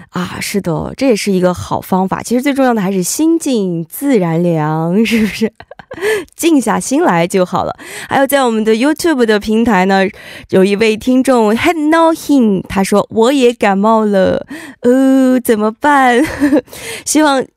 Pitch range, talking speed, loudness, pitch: 195-275 Hz, 265 characters per minute, -12 LUFS, 230 Hz